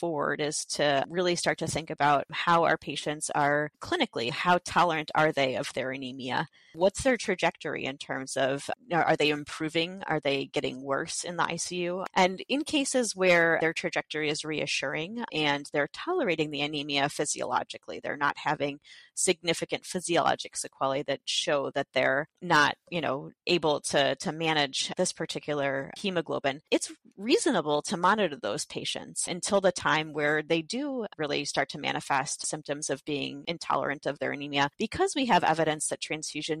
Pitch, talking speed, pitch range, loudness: 155 Hz, 160 wpm, 145-180 Hz, -28 LUFS